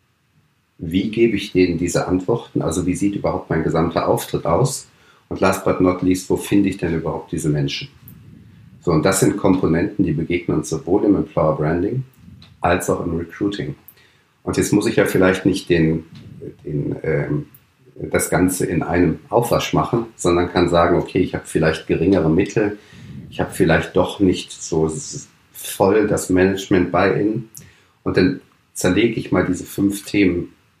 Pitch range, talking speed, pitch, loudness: 80-95 Hz, 170 wpm, 90 Hz, -19 LUFS